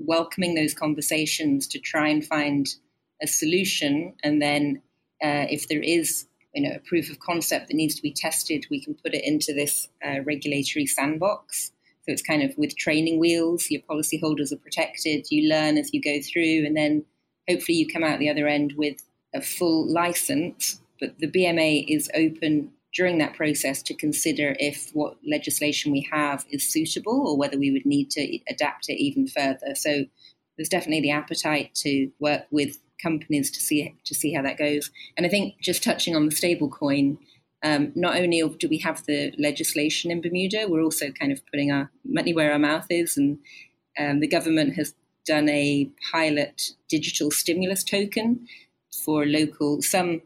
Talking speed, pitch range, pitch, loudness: 185 wpm, 145-175 Hz, 155 Hz, -24 LUFS